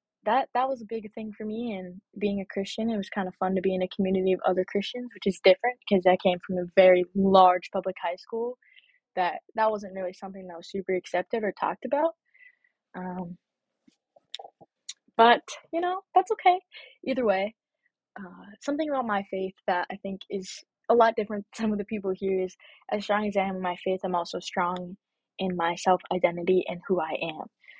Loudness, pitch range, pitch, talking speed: -27 LUFS, 185-245 Hz, 200 Hz, 205 wpm